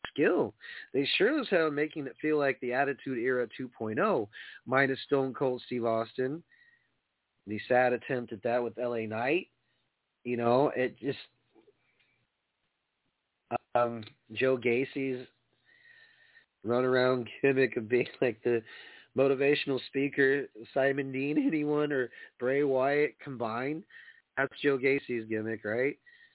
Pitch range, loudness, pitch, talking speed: 120-145 Hz, -30 LUFS, 130 Hz, 120 wpm